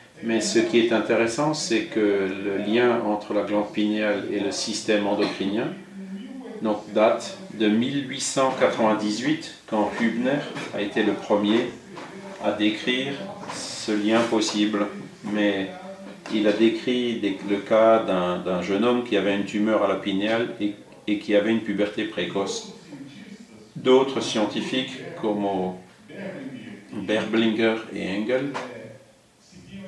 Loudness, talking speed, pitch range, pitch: -24 LUFS, 125 wpm, 105-125 Hz, 110 Hz